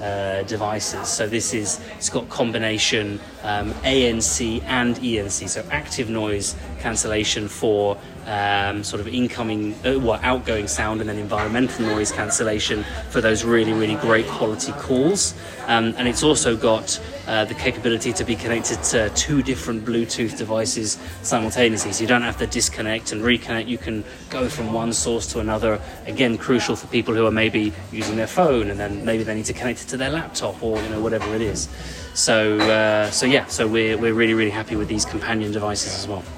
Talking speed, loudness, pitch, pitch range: 185 wpm, -21 LUFS, 110 Hz, 105-115 Hz